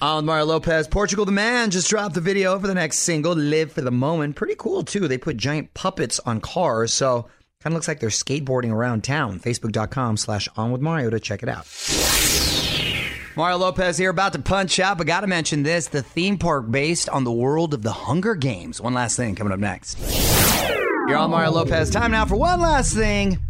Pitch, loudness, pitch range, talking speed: 155 Hz, -21 LUFS, 125-180 Hz, 215 wpm